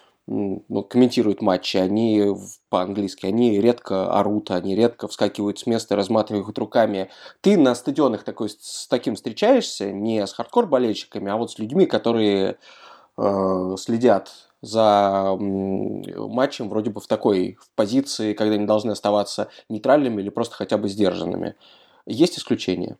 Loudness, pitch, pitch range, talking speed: -22 LUFS, 105 Hz, 95-110 Hz, 140 wpm